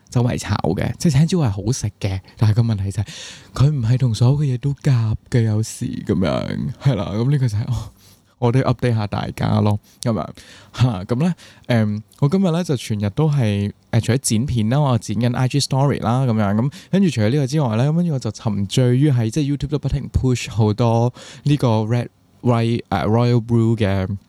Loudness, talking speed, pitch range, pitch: -19 LUFS, 375 characters per minute, 110-135 Hz, 120 Hz